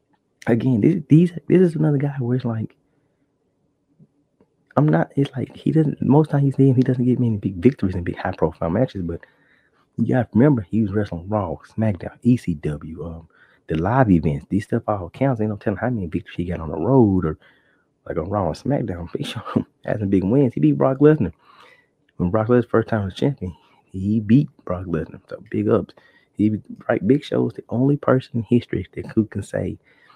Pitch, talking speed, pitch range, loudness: 110 Hz, 205 wpm, 90-130 Hz, -21 LUFS